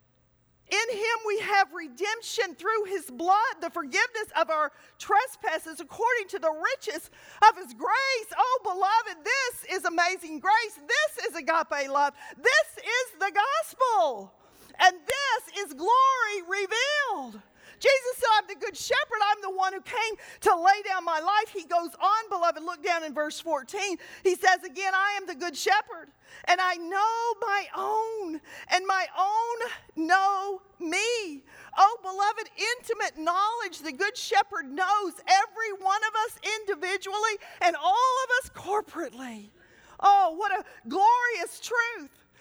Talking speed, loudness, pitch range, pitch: 150 wpm, -26 LUFS, 350-440 Hz, 395 Hz